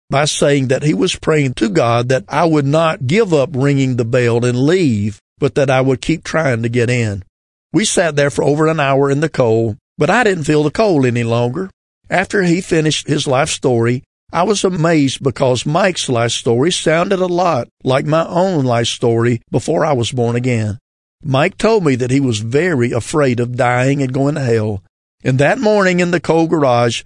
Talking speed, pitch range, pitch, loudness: 205 wpm, 120-160 Hz, 135 Hz, -15 LUFS